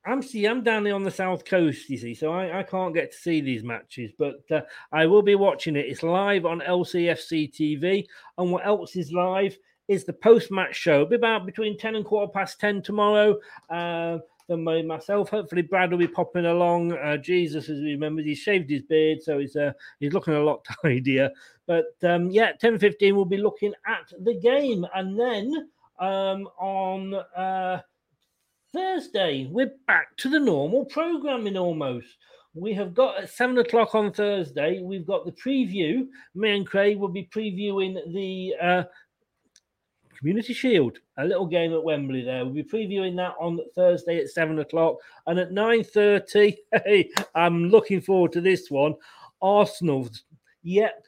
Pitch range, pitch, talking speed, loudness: 165-210 Hz, 185 Hz, 175 wpm, -24 LUFS